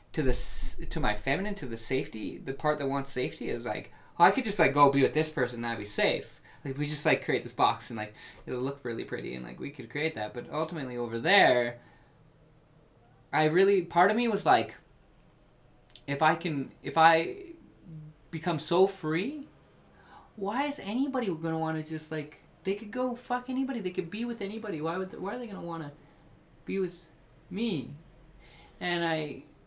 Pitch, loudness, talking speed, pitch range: 155 Hz, -30 LUFS, 200 wpm, 135-185 Hz